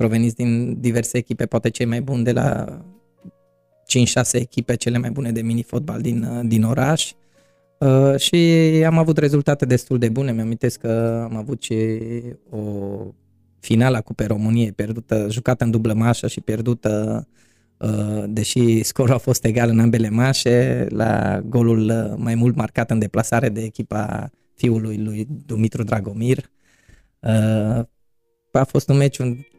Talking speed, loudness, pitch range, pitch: 150 wpm, -19 LUFS, 110-125 Hz, 115 Hz